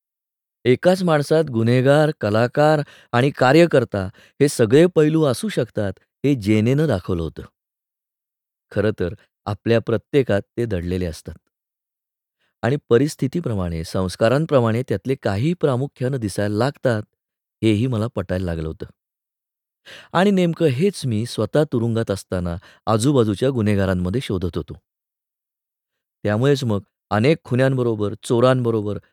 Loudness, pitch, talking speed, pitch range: -20 LUFS, 115 Hz, 105 wpm, 100-140 Hz